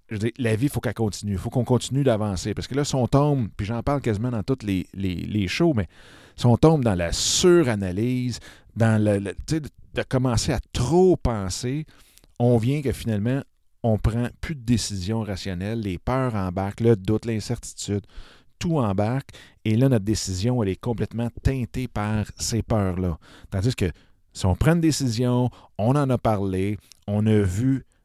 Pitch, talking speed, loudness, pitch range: 115 Hz, 190 wpm, -24 LUFS, 100-125 Hz